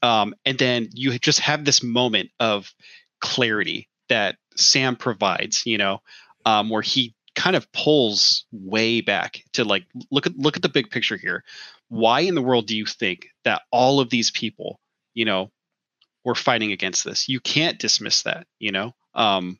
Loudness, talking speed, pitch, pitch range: -21 LUFS, 180 wpm, 120 Hz, 110-130 Hz